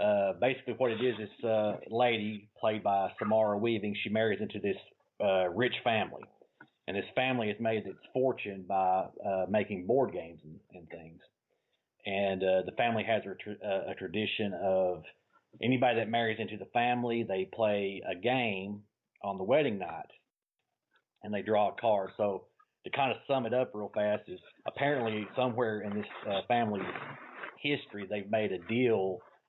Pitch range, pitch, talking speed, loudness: 100-120 Hz, 105 Hz, 175 wpm, -32 LUFS